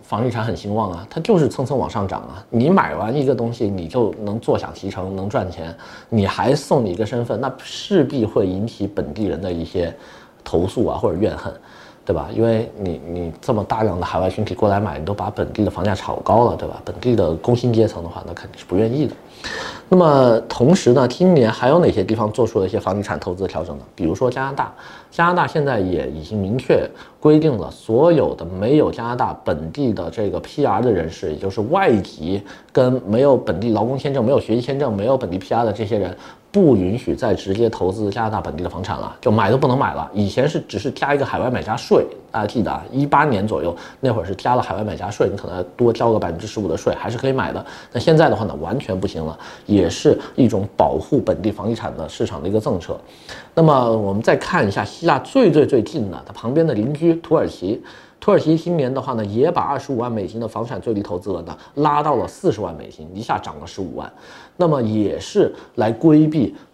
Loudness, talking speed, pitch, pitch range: -19 LUFS, 340 characters per minute, 110 Hz, 95-125 Hz